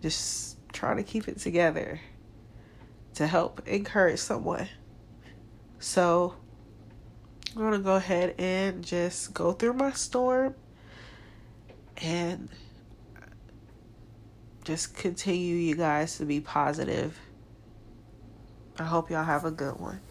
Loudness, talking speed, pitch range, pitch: -29 LUFS, 105 wpm, 110-170 Hz, 120 Hz